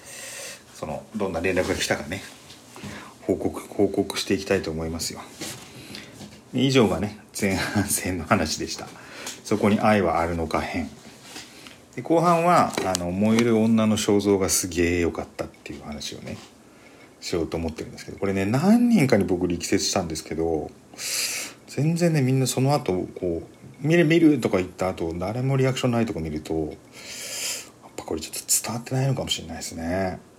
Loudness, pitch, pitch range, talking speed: -24 LUFS, 100 Hz, 85-130 Hz, 330 characters per minute